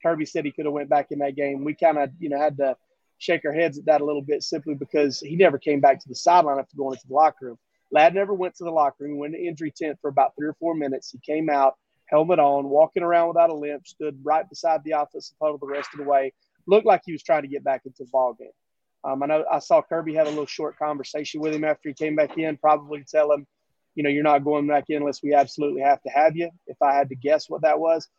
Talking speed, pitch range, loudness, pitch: 285 wpm, 145-160 Hz, -23 LUFS, 150 Hz